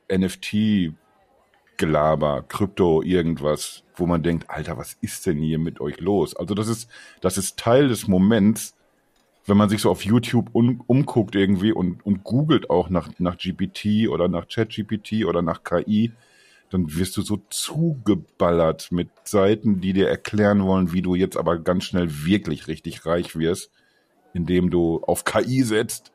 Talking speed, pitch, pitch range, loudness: 160 wpm, 95 Hz, 85-110 Hz, -22 LUFS